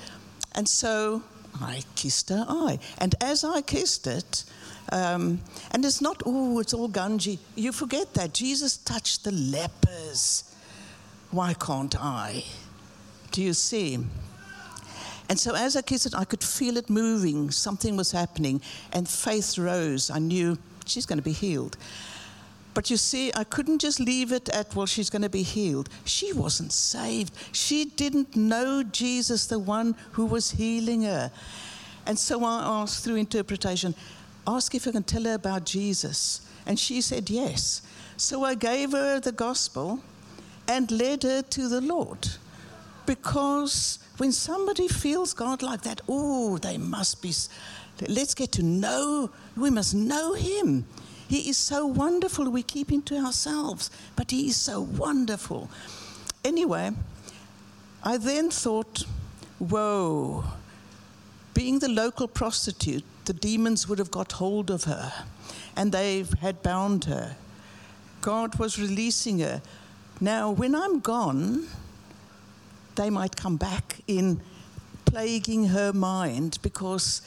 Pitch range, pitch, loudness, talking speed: 170-255 Hz, 215 Hz, -27 LUFS, 145 wpm